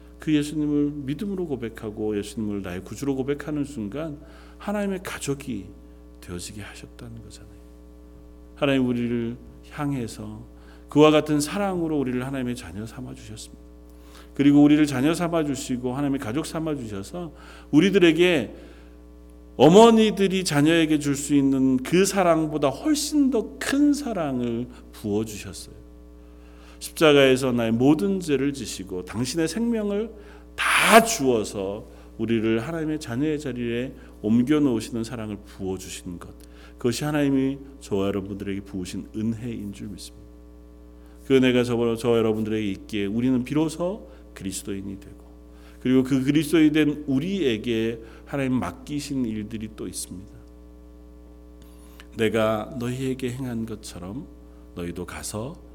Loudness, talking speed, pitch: -23 LUFS, 310 characters per minute, 115 Hz